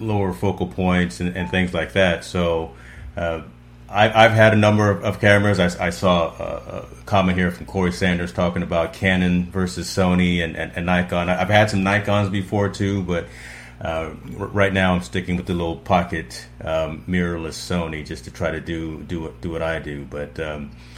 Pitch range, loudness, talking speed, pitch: 80-95 Hz, -20 LUFS, 200 wpm, 90 Hz